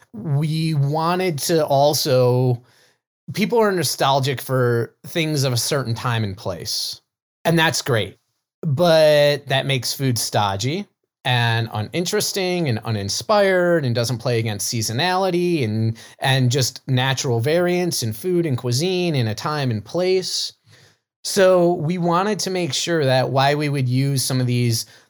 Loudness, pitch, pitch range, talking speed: -20 LUFS, 135 Hz, 120-170 Hz, 145 wpm